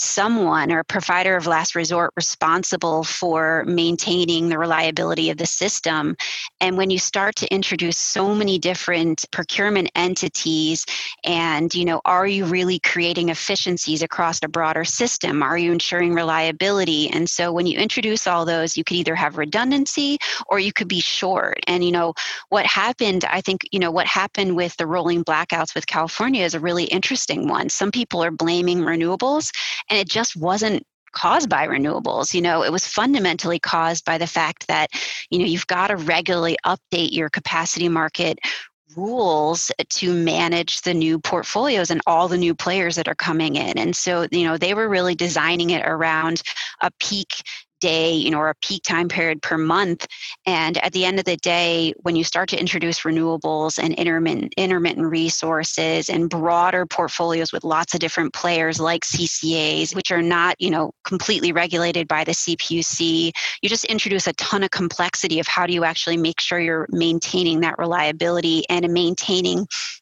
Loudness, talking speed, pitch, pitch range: -20 LUFS, 175 wpm, 170 Hz, 165-185 Hz